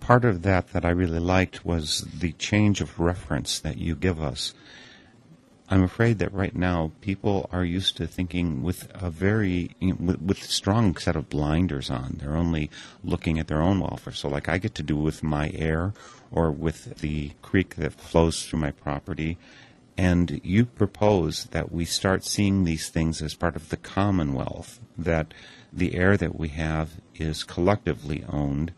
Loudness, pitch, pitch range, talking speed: -26 LUFS, 85 Hz, 80-95 Hz, 175 wpm